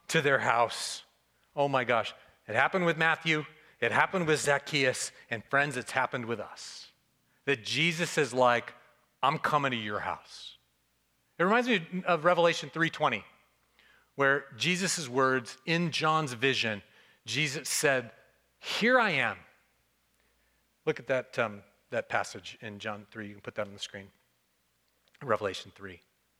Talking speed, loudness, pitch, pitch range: 145 wpm, -29 LUFS, 130 Hz, 110-155 Hz